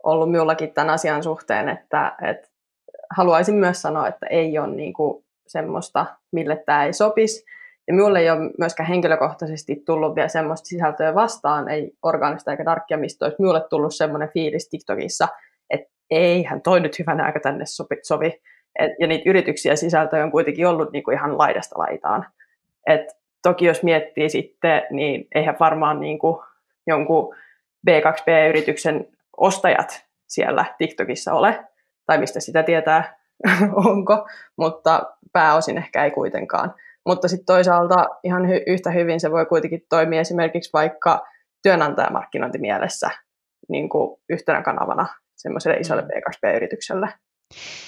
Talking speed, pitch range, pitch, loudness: 135 wpm, 155-180 Hz, 165 Hz, -20 LUFS